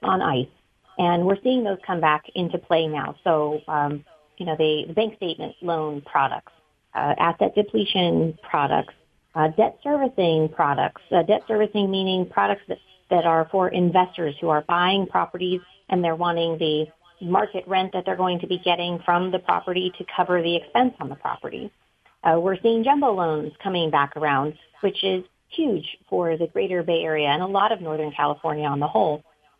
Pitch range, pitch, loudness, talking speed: 155-190 Hz, 175 Hz, -23 LUFS, 180 wpm